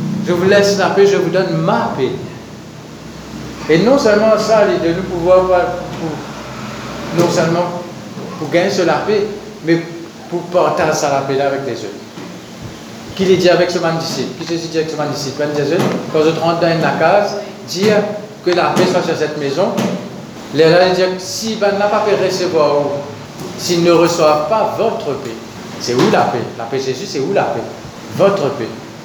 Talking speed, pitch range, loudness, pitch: 190 wpm, 155-200 Hz, -15 LUFS, 175 Hz